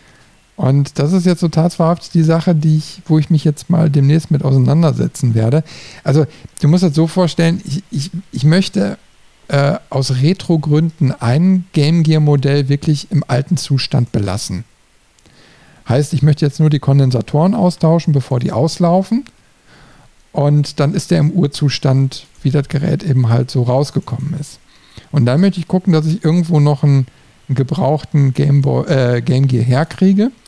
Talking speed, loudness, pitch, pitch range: 160 wpm, -14 LUFS, 150 Hz, 135-165 Hz